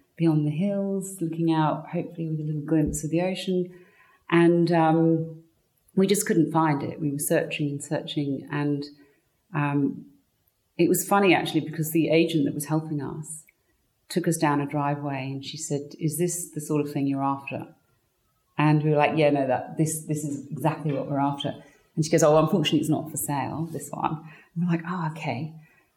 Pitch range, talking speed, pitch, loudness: 145-165 Hz, 195 wpm, 155 Hz, -25 LUFS